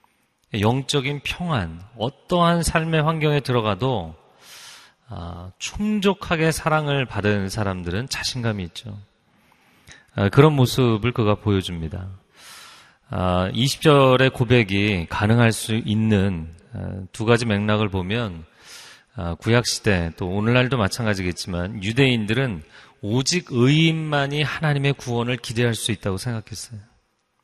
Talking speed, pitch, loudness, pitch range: 245 characters per minute, 115 Hz, -21 LUFS, 100-135 Hz